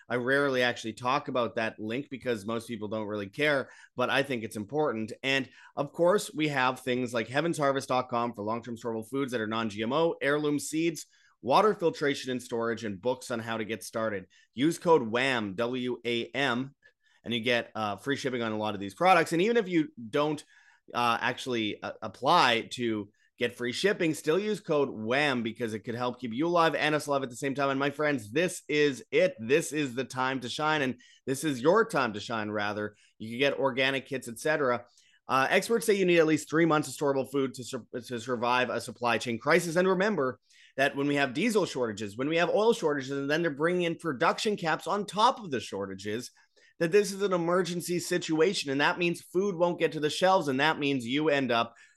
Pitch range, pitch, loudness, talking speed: 120-155 Hz, 135 Hz, -29 LUFS, 220 wpm